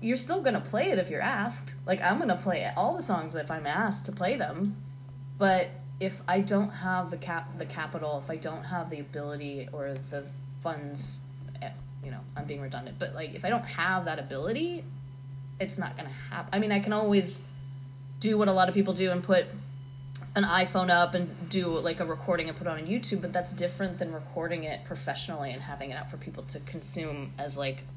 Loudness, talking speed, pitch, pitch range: -31 LUFS, 215 wpm, 155 Hz, 135-180 Hz